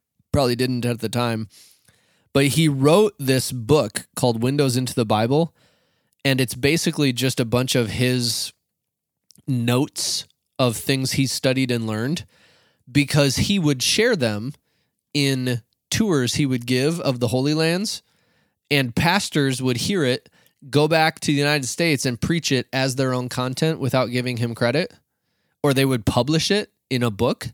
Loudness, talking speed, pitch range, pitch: -21 LUFS, 160 wpm, 125-150 Hz, 130 Hz